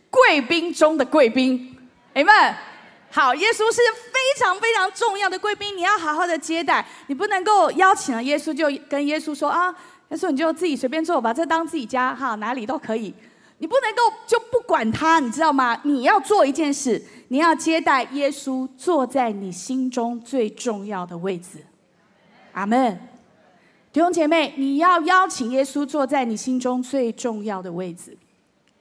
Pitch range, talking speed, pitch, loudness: 250-355 Hz, 255 characters per minute, 290 Hz, -20 LUFS